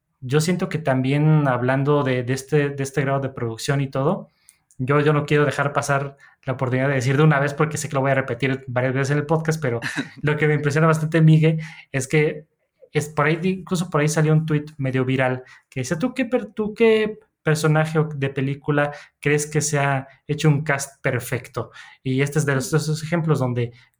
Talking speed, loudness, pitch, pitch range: 210 wpm, -21 LUFS, 145 Hz, 135-155 Hz